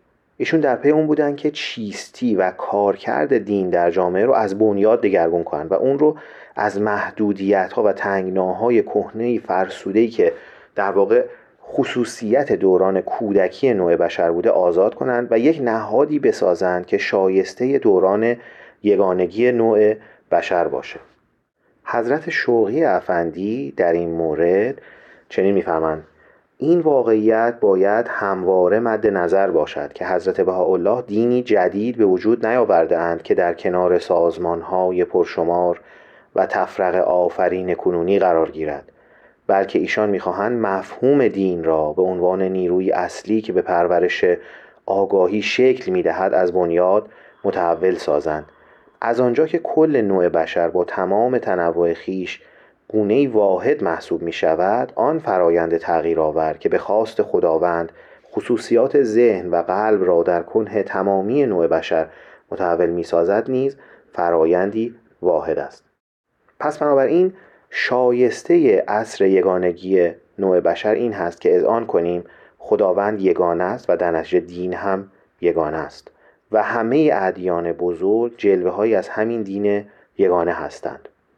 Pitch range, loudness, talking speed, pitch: 90-115 Hz, -18 LUFS, 130 wpm, 95 Hz